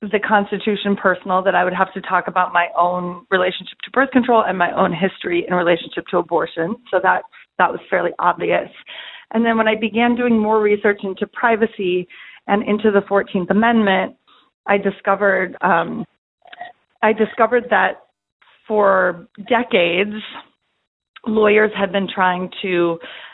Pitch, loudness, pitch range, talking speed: 200 Hz, -18 LUFS, 185-225 Hz, 150 wpm